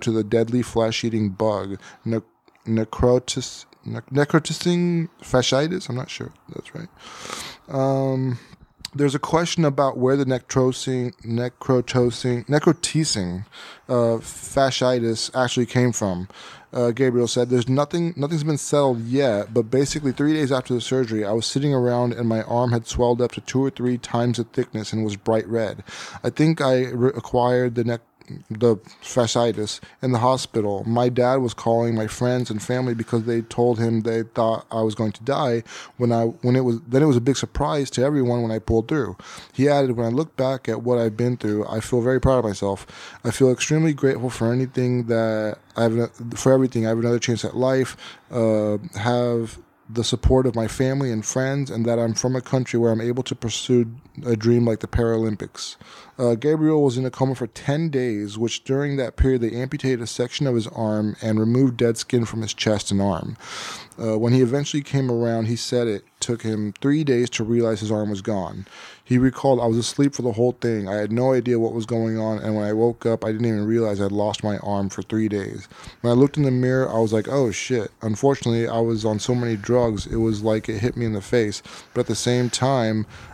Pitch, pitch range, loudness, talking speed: 120 Hz, 115-130 Hz, -22 LUFS, 205 wpm